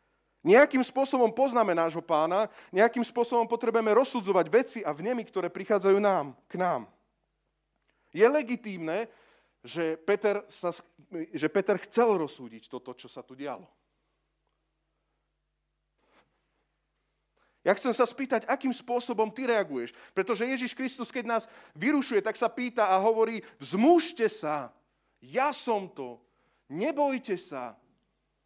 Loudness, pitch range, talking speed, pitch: -28 LUFS, 175-245 Hz, 115 wpm, 220 Hz